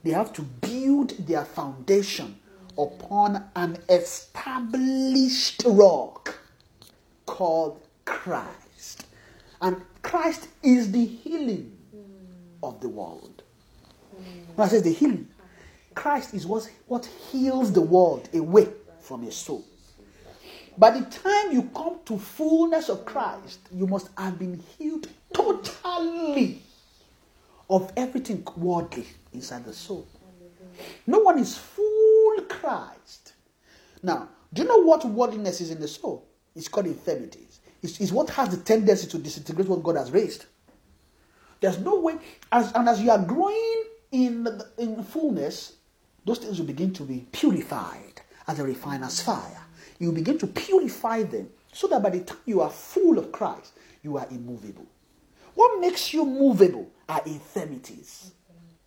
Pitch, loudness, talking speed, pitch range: 220 Hz, -24 LUFS, 135 wpm, 175-290 Hz